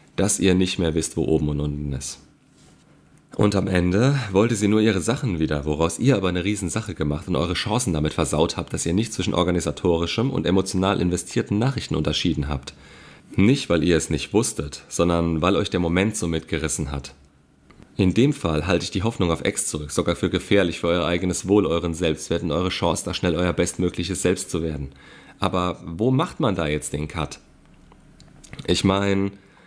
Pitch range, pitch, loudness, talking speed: 80-95 Hz, 90 Hz, -22 LUFS, 190 wpm